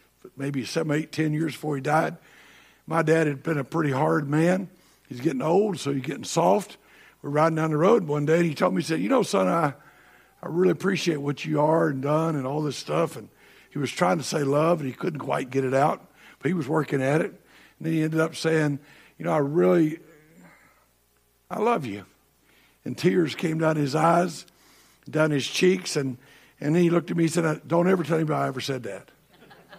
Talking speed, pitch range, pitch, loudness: 225 wpm, 145-170 Hz, 155 Hz, -24 LUFS